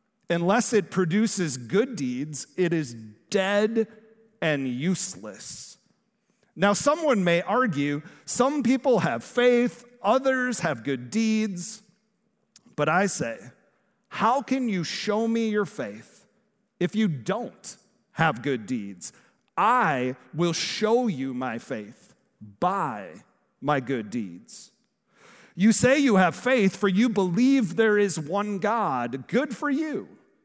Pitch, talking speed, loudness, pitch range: 210 Hz, 125 wpm, -25 LUFS, 170-230 Hz